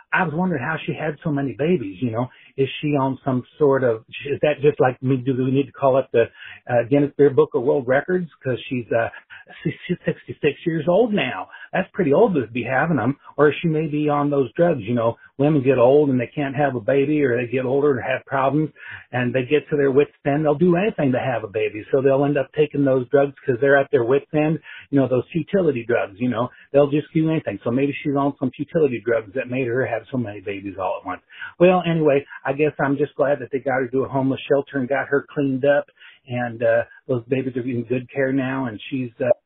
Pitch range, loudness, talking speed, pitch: 130-150 Hz, -21 LUFS, 245 wpm, 140 Hz